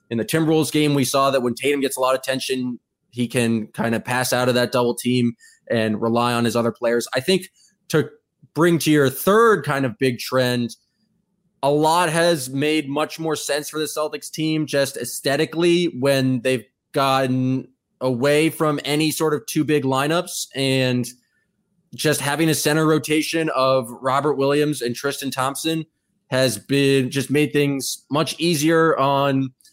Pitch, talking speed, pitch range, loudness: 140 Hz, 170 wpm, 130-155 Hz, -20 LUFS